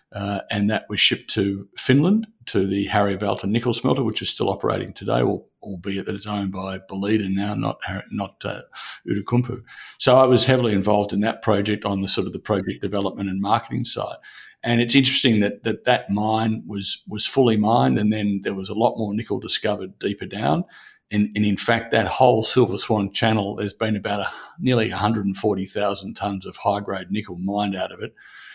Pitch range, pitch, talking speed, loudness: 100-115 Hz, 105 Hz, 195 wpm, -22 LUFS